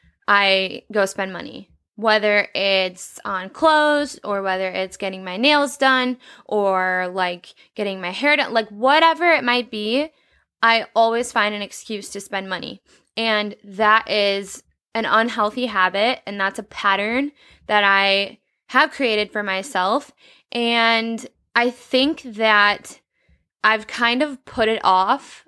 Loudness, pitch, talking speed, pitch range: -19 LUFS, 215 Hz, 140 wpm, 195-250 Hz